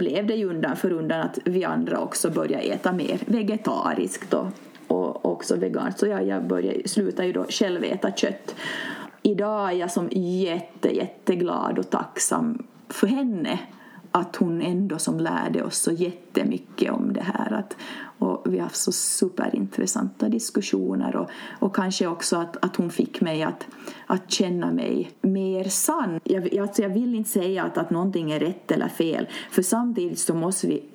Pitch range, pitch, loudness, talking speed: 175-220 Hz, 190 Hz, -25 LUFS, 170 wpm